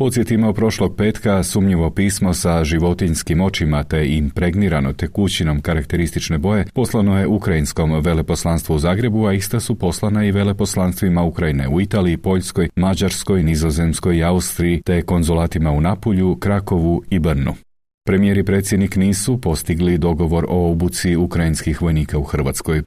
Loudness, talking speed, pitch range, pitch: -18 LUFS, 135 wpm, 80-100 Hz, 90 Hz